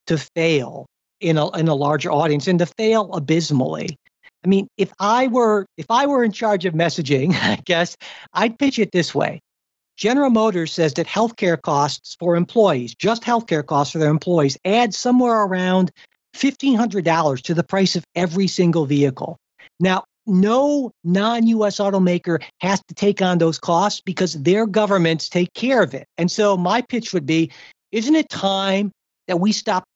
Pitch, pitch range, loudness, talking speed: 185 Hz, 165-215 Hz, -19 LUFS, 170 wpm